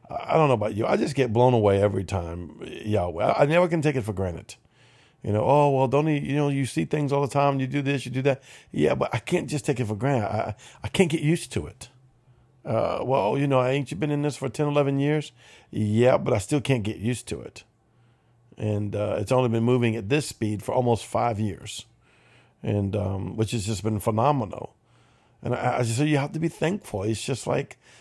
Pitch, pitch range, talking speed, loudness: 125 Hz, 110-140 Hz, 240 wpm, -25 LUFS